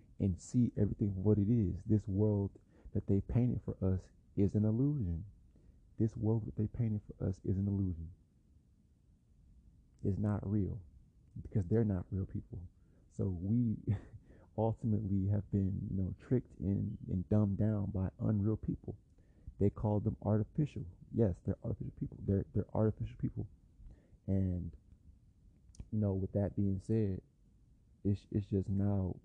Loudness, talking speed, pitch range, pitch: -36 LUFS, 150 wpm, 95-110 Hz, 100 Hz